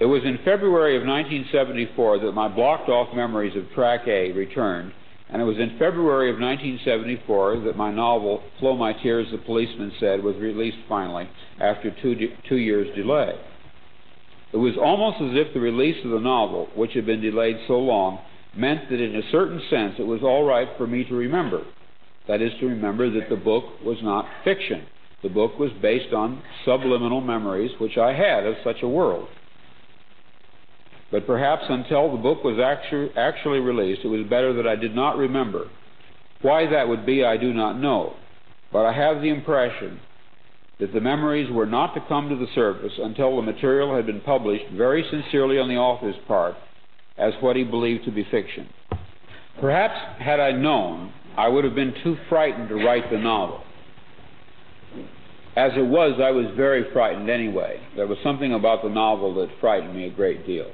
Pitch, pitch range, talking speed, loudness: 120 Hz, 110-135 Hz, 185 wpm, -23 LUFS